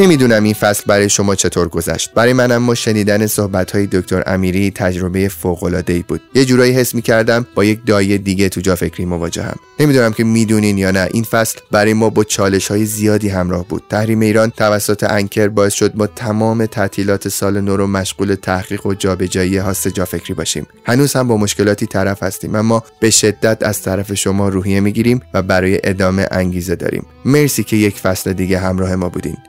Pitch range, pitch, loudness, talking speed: 95-110 Hz, 100 Hz, -14 LUFS, 195 wpm